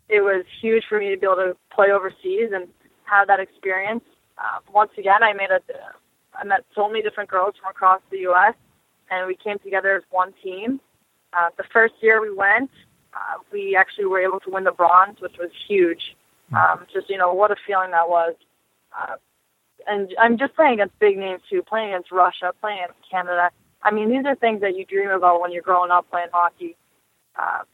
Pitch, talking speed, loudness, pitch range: 195 Hz, 210 wpm, -20 LUFS, 185-215 Hz